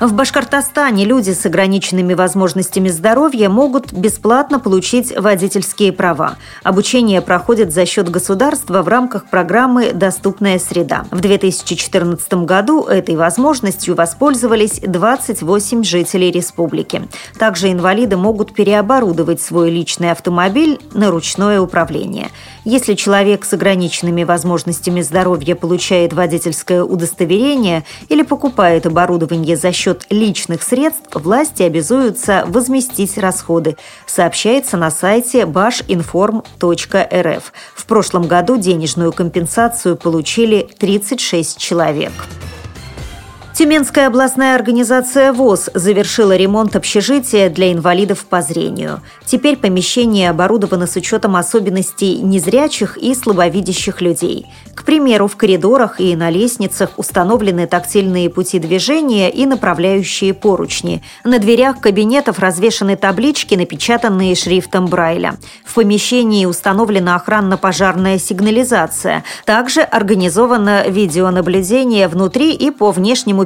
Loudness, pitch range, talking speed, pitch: -13 LUFS, 180-230 Hz, 105 wpm, 195 Hz